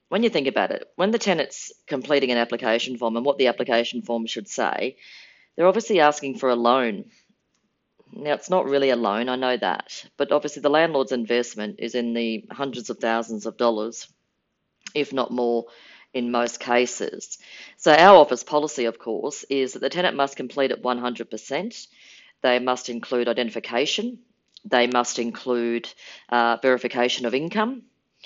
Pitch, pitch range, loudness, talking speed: 125 Hz, 120-140 Hz, -23 LUFS, 165 wpm